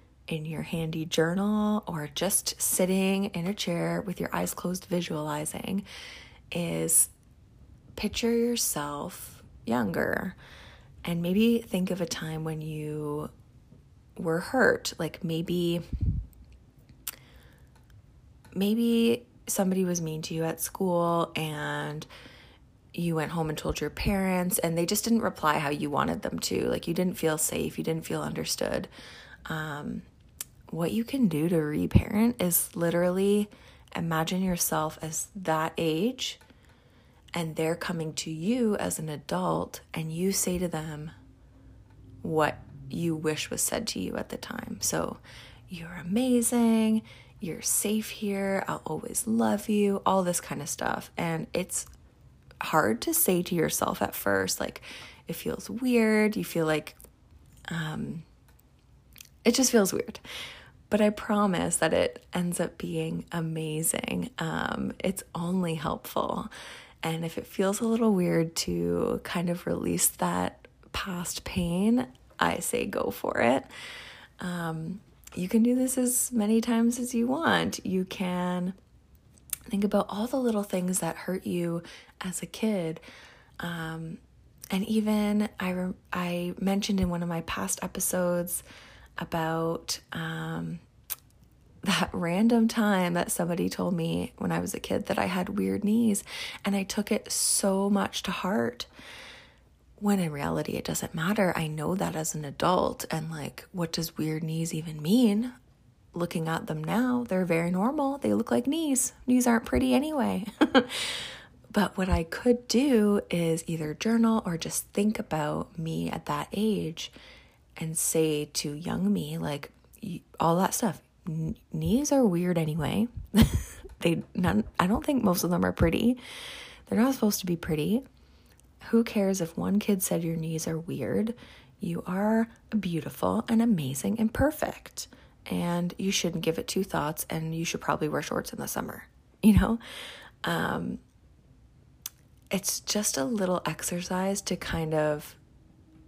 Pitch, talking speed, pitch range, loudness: 180 Hz, 150 wpm, 160-210 Hz, -28 LUFS